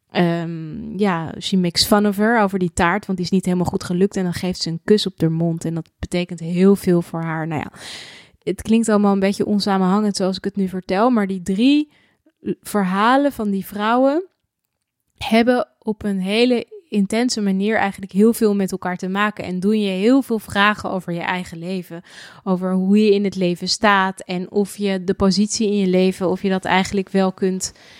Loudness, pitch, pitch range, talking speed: -19 LUFS, 195 Hz, 185-210 Hz, 210 wpm